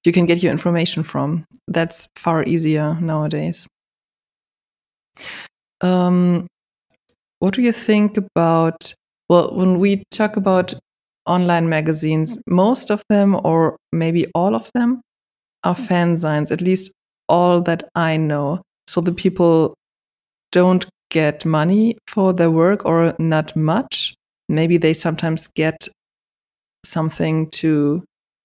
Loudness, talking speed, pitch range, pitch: -18 LUFS, 120 wpm, 160-185 Hz, 170 Hz